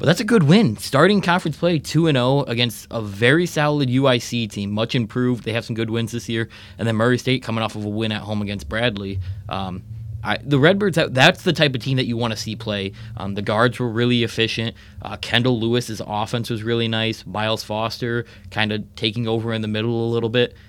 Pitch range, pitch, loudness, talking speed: 105-125 Hz, 115 Hz, -20 LUFS, 230 wpm